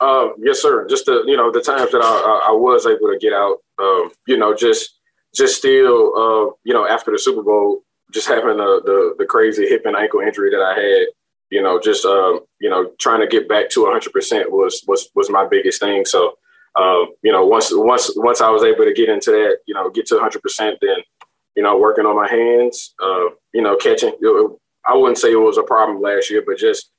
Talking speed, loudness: 235 wpm, -15 LUFS